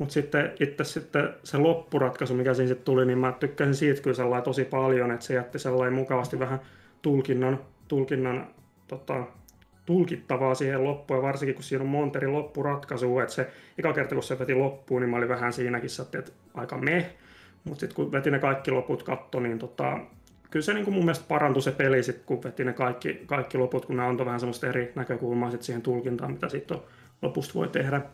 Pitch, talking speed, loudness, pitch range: 130 Hz, 195 wpm, -28 LUFS, 125-140 Hz